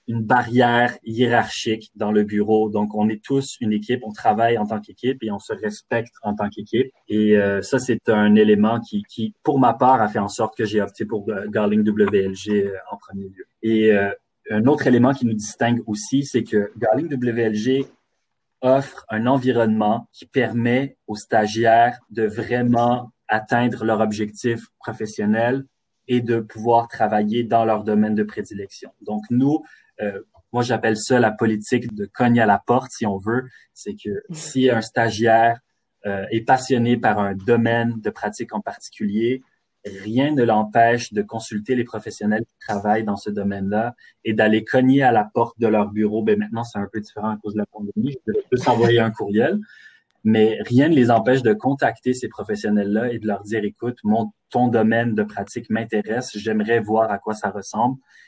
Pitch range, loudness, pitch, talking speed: 105-120 Hz, -20 LUFS, 110 Hz, 180 wpm